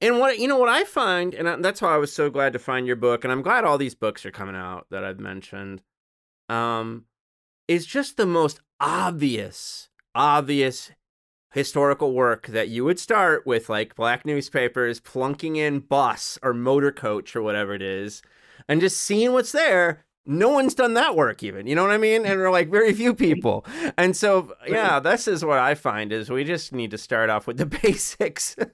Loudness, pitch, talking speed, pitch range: -22 LUFS, 140 Hz, 205 wpm, 115-185 Hz